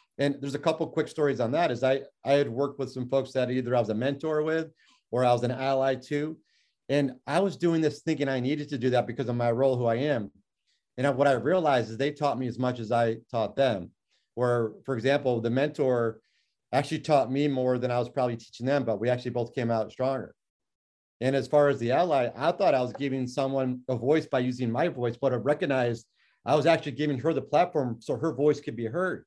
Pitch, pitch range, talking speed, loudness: 135 Hz, 120-145 Hz, 240 wpm, -27 LUFS